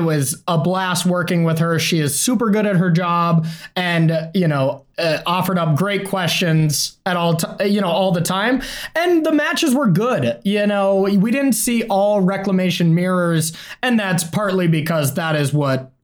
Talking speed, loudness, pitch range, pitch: 185 wpm, -18 LUFS, 165-205 Hz, 180 Hz